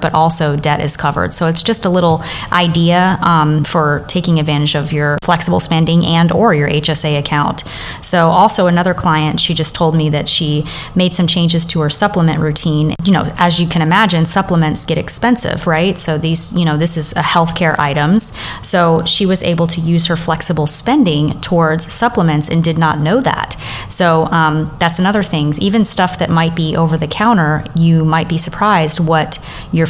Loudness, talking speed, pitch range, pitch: -12 LUFS, 190 wpm, 155-175 Hz, 165 Hz